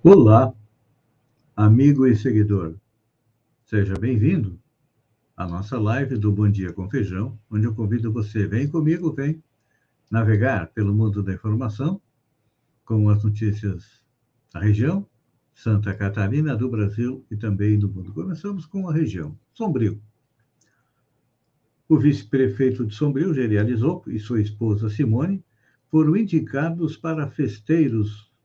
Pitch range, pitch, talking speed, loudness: 105-140 Hz, 115 Hz, 120 wpm, -22 LUFS